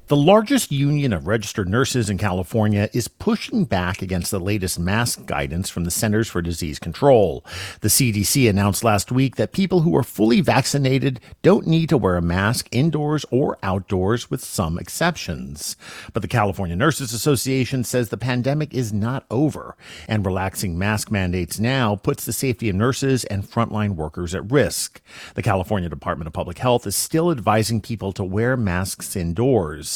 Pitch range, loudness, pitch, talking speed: 95-130 Hz, -21 LUFS, 110 Hz, 170 wpm